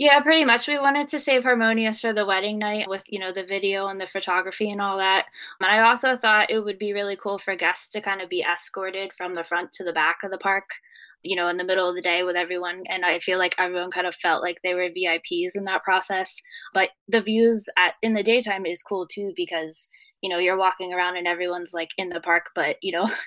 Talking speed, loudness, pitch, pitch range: 255 wpm, -23 LUFS, 190 Hz, 180-210 Hz